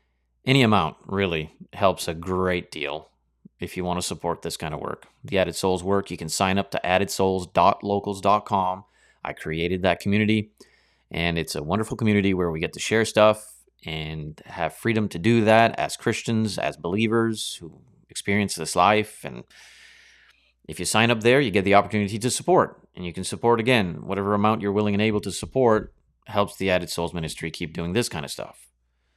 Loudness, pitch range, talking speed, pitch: -23 LUFS, 85-110 Hz, 185 wpm, 100 Hz